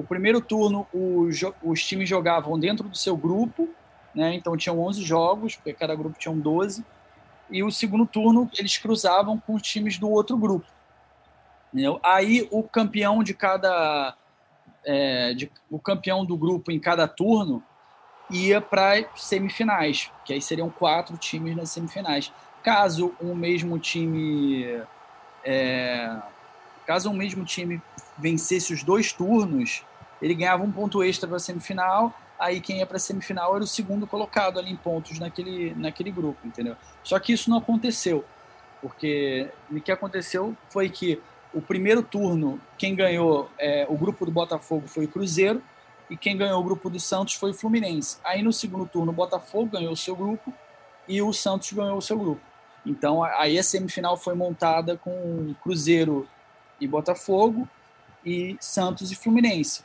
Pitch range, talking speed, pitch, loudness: 165-205 Hz, 160 wpm, 185 Hz, -25 LUFS